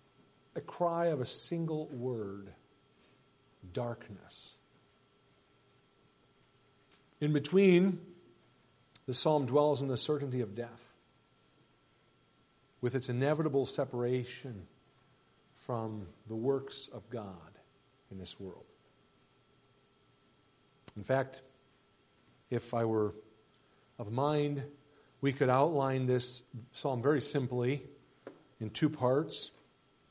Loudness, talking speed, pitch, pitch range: -34 LUFS, 90 wpm, 135 Hz, 120-140 Hz